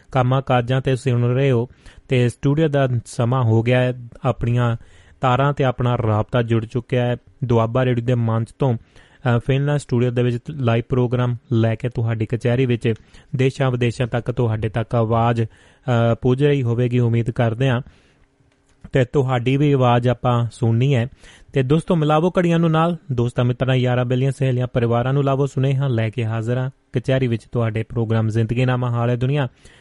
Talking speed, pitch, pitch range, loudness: 170 wpm, 125 Hz, 115-135 Hz, -20 LUFS